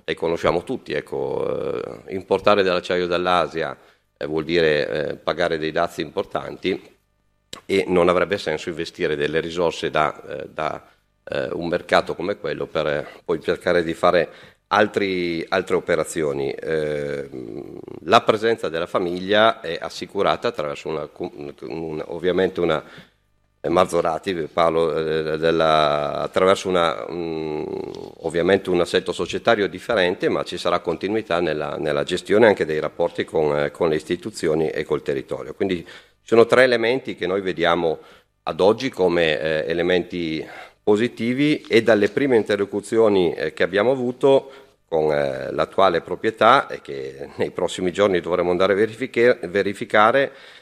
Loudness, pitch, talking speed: -21 LUFS, 100 Hz, 130 wpm